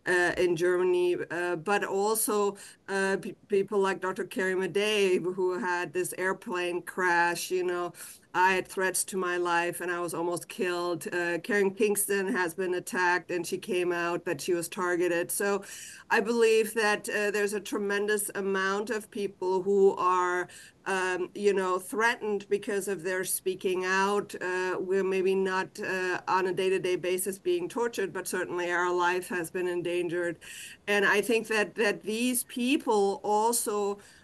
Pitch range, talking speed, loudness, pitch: 180-205 Hz, 165 wpm, -28 LUFS, 185 Hz